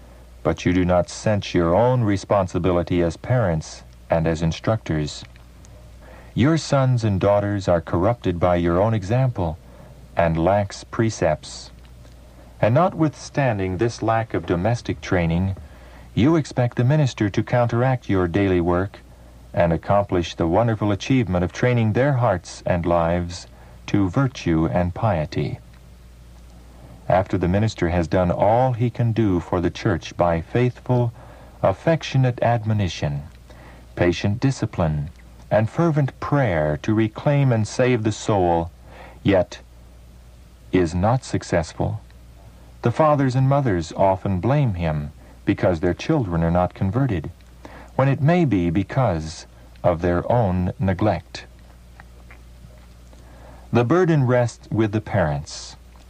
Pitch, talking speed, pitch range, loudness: 90 Hz, 125 wpm, 75-115 Hz, -21 LUFS